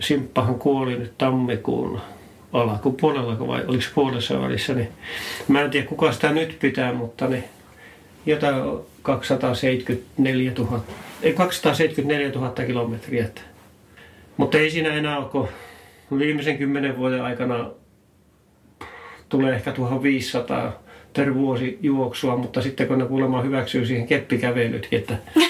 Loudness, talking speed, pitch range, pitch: -23 LUFS, 125 wpm, 120-140 Hz, 130 Hz